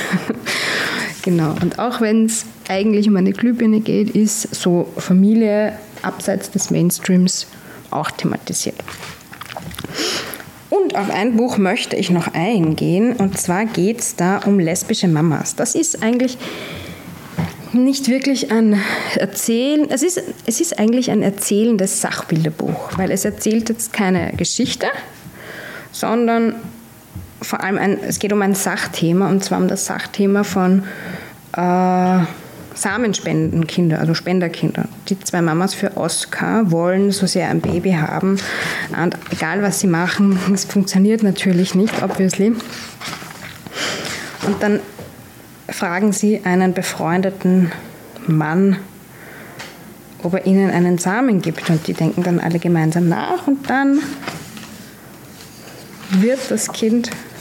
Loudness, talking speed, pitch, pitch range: -17 LUFS, 125 wpm, 195 Hz, 180-220 Hz